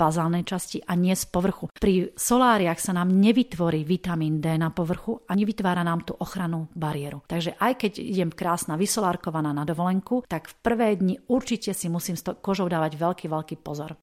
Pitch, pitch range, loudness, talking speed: 180 Hz, 165-195 Hz, -25 LUFS, 185 wpm